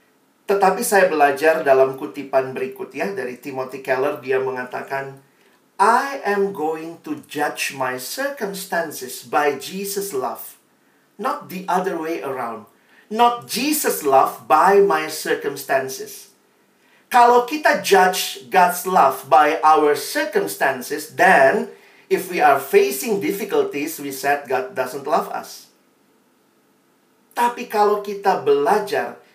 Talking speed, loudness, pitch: 115 wpm, -19 LUFS, 190 Hz